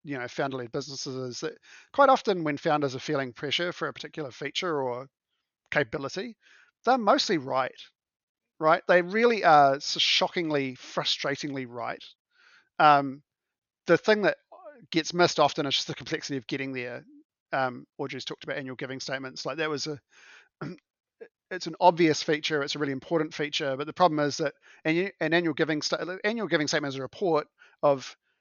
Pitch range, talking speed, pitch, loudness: 135-175 Hz, 165 wpm, 150 Hz, -27 LUFS